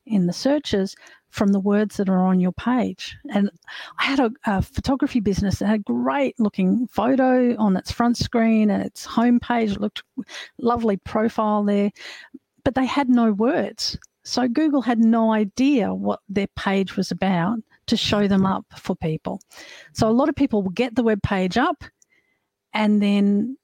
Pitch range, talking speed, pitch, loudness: 200-245 Hz, 180 wpm, 220 Hz, -21 LUFS